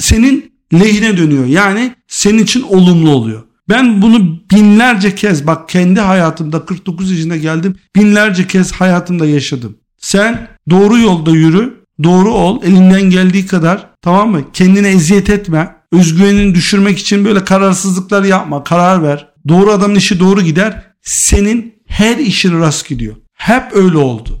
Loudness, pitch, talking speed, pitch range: -9 LUFS, 185 Hz, 140 wpm, 165-205 Hz